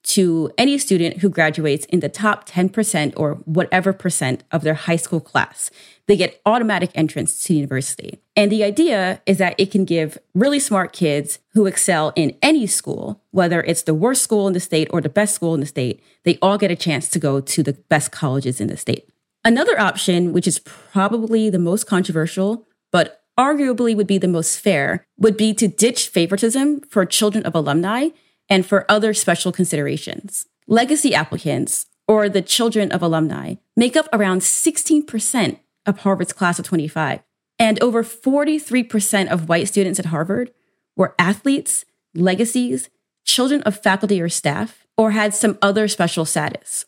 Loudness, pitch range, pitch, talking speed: -18 LUFS, 165-220 Hz, 195 Hz, 175 wpm